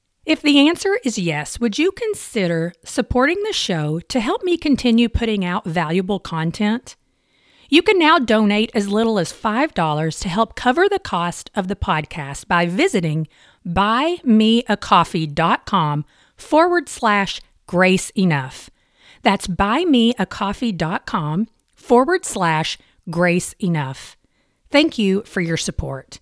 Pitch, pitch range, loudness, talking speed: 205 Hz, 175-250 Hz, -18 LUFS, 120 wpm